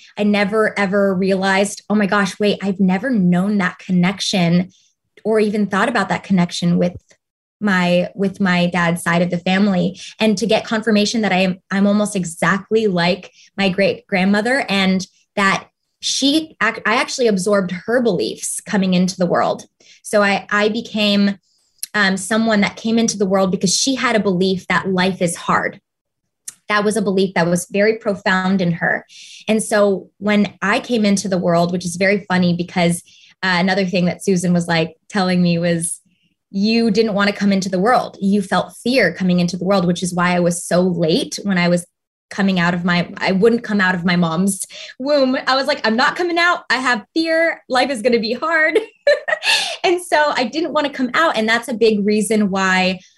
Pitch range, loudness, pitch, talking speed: 185-220 Hz, -17 LUFS, 200 Hz, 195 wpm